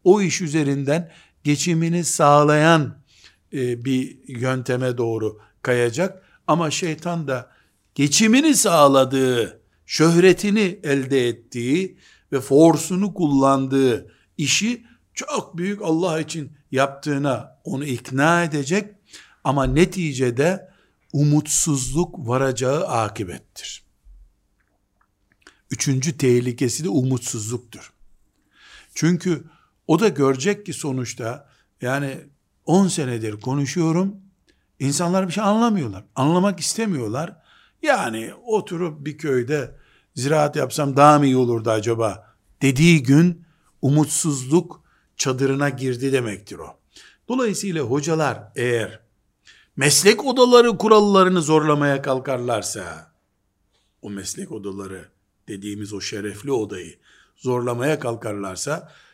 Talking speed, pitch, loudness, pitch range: 90 wpm, 140 Hz, -20 LUFS, 125-170 Hz